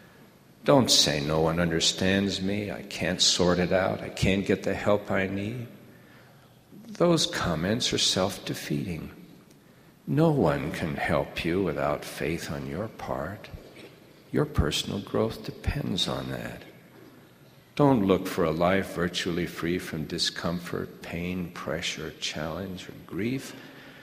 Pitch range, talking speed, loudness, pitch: 85-100 Hz, 130 wpm, -27 LUFS, 90 Hz